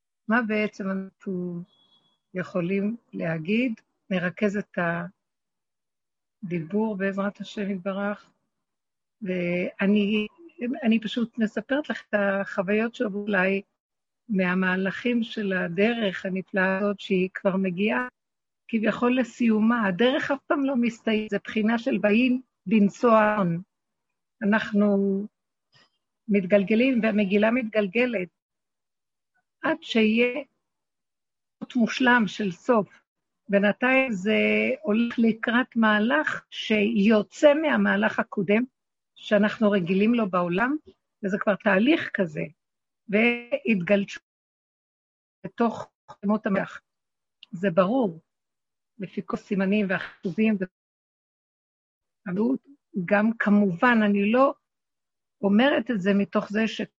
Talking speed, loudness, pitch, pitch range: 90 wpm, -24 LUFS, 210 Hz, 200-235 Hz